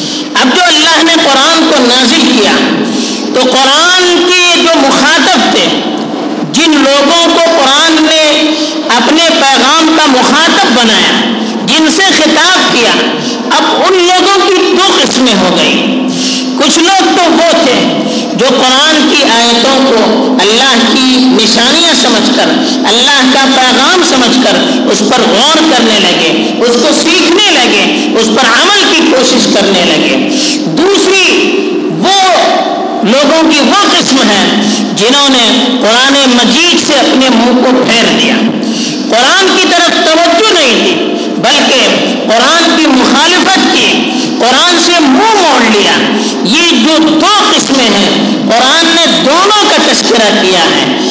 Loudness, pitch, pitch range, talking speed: -5 LUFS, 280 Hz, 255-330 Hz, 135 wpm